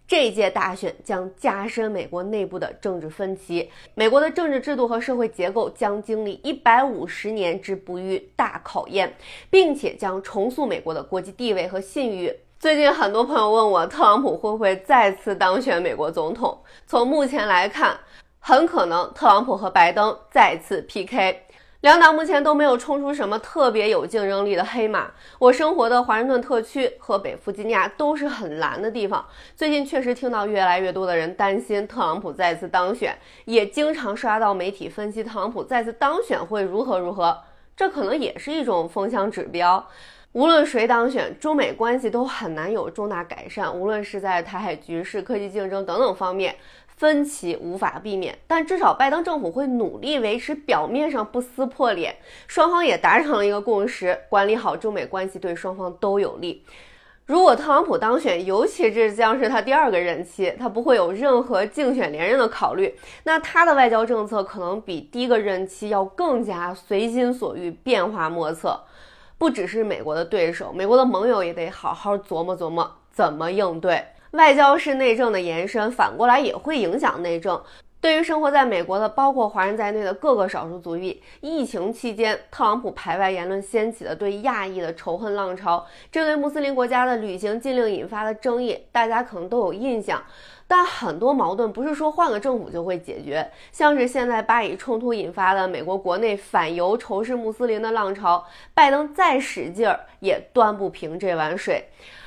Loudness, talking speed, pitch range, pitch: -21 LUFS, 290 characters per minute, 190-275 Hz, 220 Hz